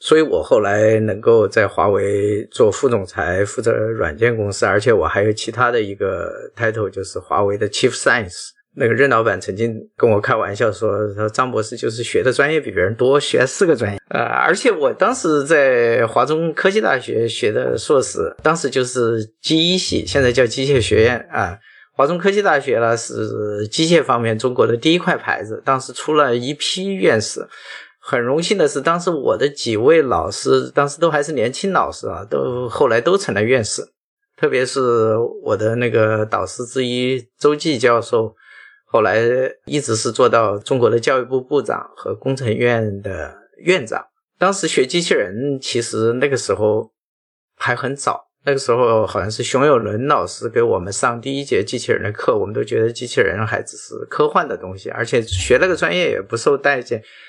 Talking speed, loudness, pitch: 295 characters per minute, -17 LUFS, 150 Hz